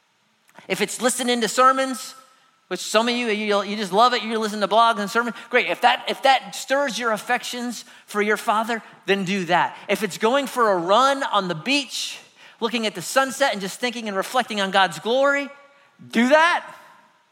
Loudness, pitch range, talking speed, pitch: -21 LUFS, 205-260 Hz, 195 wpm, 235 Hz